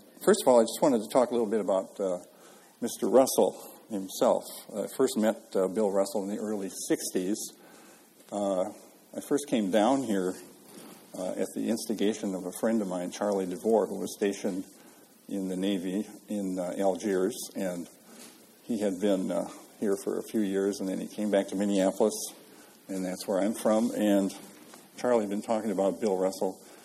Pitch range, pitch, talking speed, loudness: 95-105 Hz, 100 Hz, 185 wpm, -29 LUFS